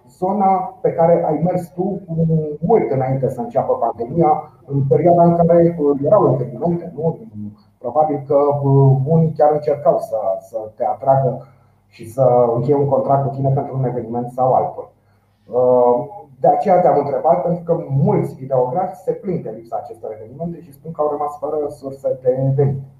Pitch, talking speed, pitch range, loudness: 145 Hz, 160 wpm, 130-170 Hz, -17 LUFS